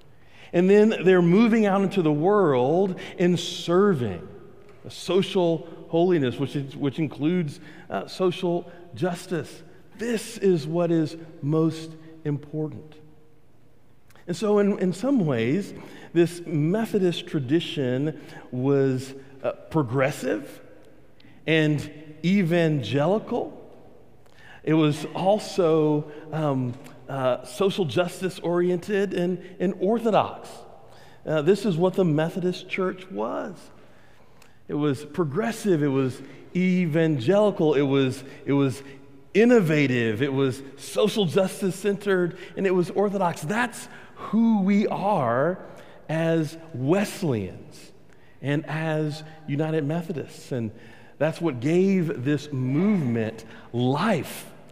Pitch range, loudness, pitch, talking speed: 140-185 Hz, -24 LUFS, 160 Hz, 105 wpm